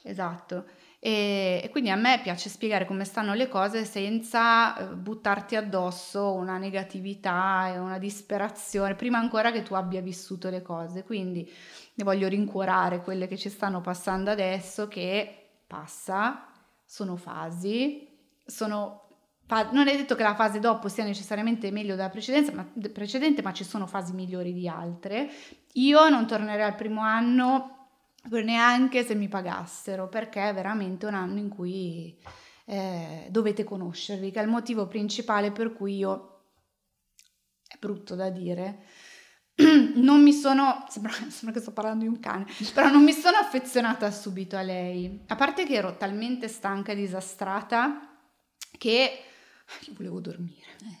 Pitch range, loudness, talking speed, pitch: 190-230 Hz, -26 LUFS, 145 wpm, 205 Hz